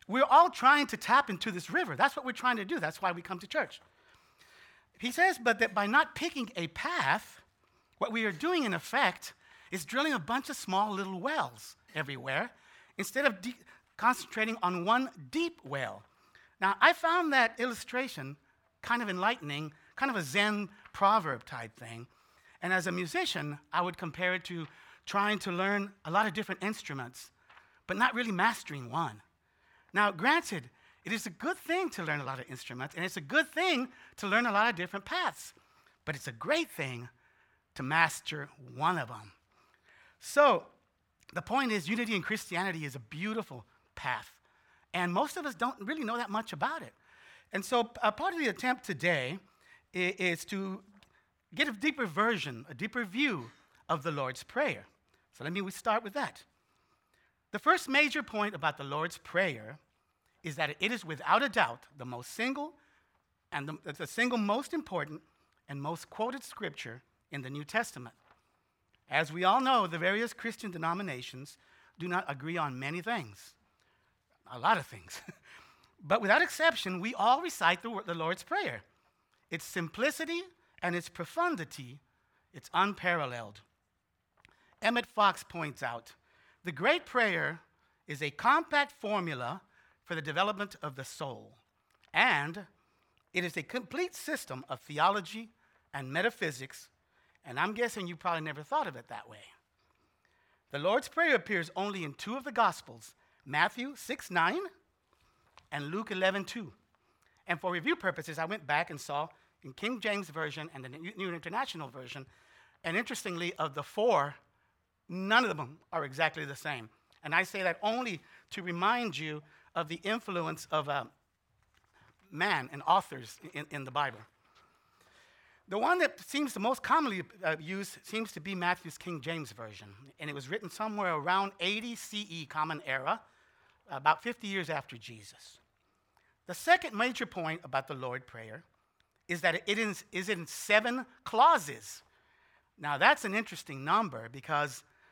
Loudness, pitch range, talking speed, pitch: -32 LUFS, 155-235 Hz, 165 wpm, 185 Hz